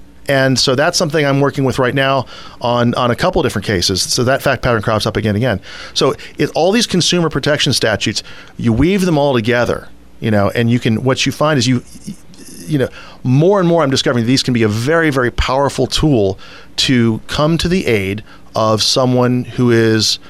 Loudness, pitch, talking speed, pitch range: -14 LUFS, 125 Hz, 210 wpm, 115-145 Hz